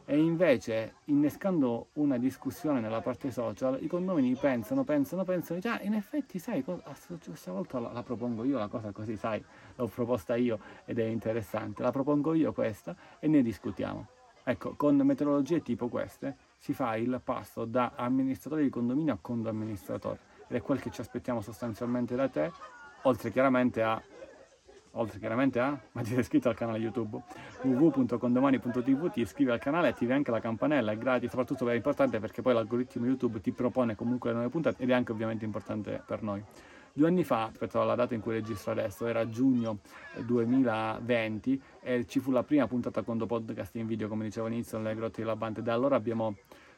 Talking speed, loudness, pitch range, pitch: 185 wpm, -31 LUFS, 115-140 Hz, 120 Hz